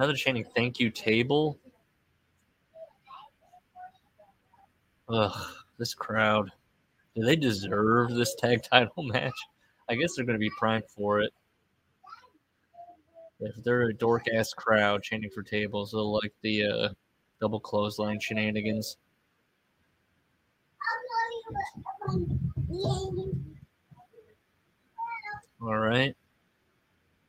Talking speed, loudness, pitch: 90 wpm, -29 LUFS, 115 Hz